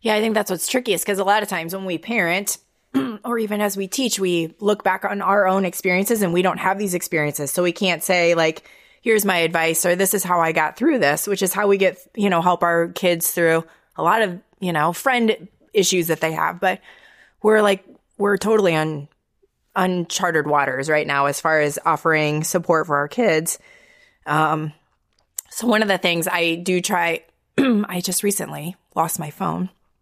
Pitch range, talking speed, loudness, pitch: 165-205 Hz, 205 wpm, -20 LUFS, 180 Hz